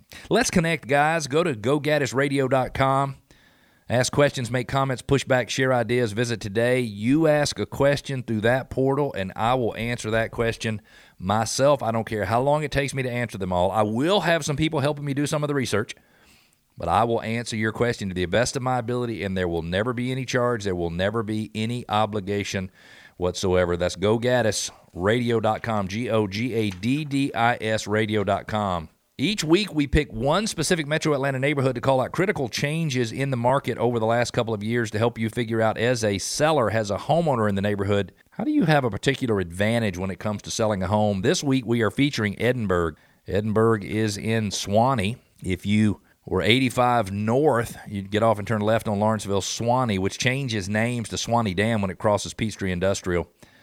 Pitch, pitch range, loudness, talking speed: 115 Hz, 105-130 Hz, -24 LUFS, 190 wpm